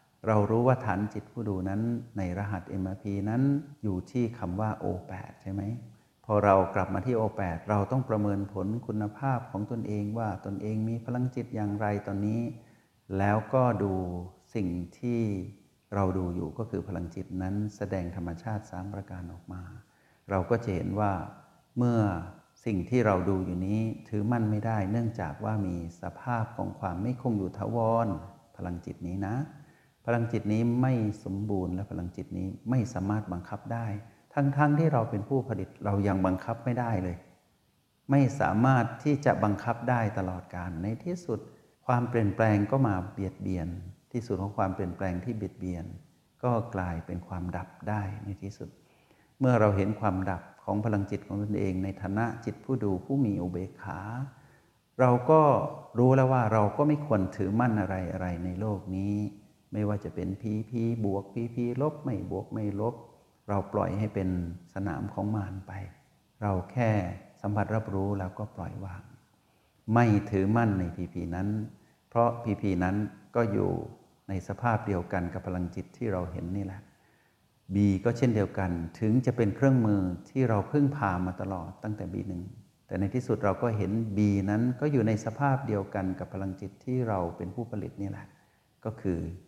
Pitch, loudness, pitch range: 105 Hz, -30 LUFS, 95-115 Hz